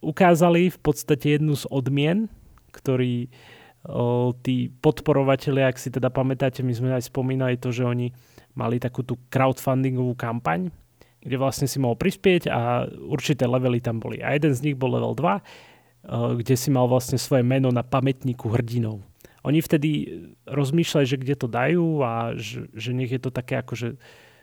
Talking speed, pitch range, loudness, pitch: 170 wpm, 120-145 Hz, -24 LUFS, 130 Hz